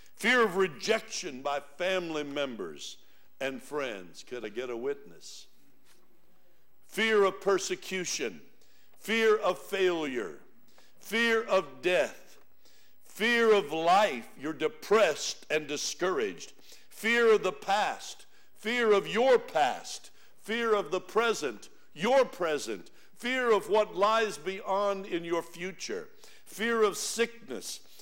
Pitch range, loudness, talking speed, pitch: 180-230 Hz, -29 LUFS, 115 wpm, 205 Hz